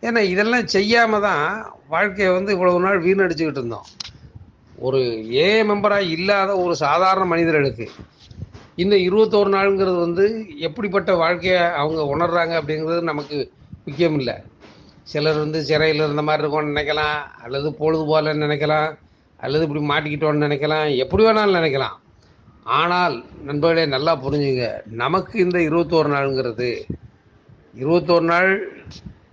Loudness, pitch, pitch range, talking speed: -19 LUFS, 165 Hz, 150-190 Hz, 115 wpm